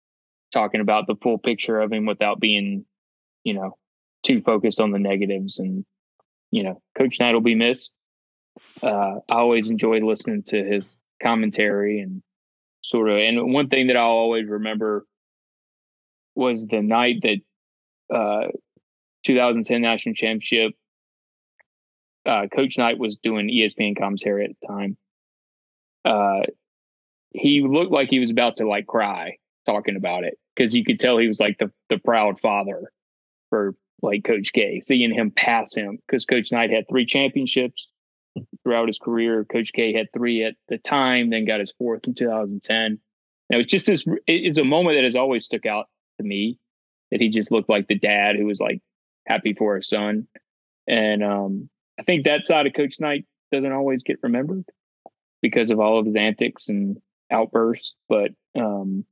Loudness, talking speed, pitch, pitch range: -21 LUFS, 170 wpm, 110 Hz, 105-125 Hz